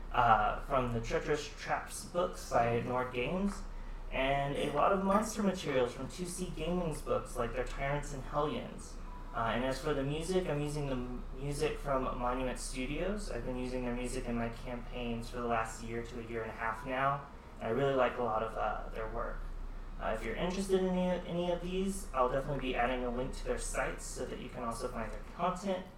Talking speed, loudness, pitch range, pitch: 215 wpm, -35 LUFS, 120-155 Hz, 130 Hz